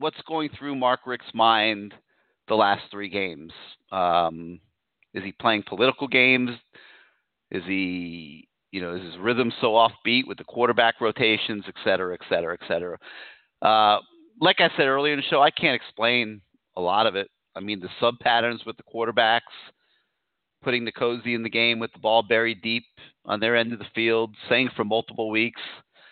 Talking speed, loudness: 180 wpm, -23 LUFS